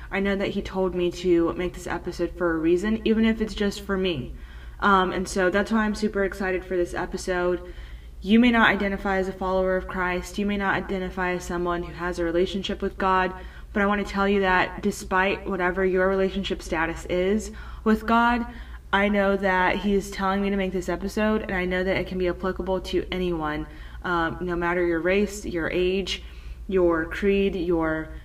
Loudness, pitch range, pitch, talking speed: -24 LUFS, 180-200 Hz, 185 Hz, 205 wpm